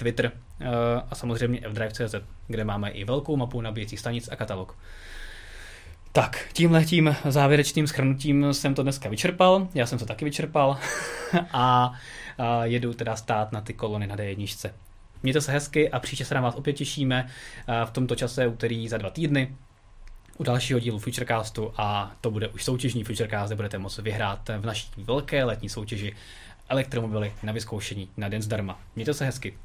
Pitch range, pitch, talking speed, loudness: 105-135 Hz, 115 Hz, 170 wpm, -27 LUFS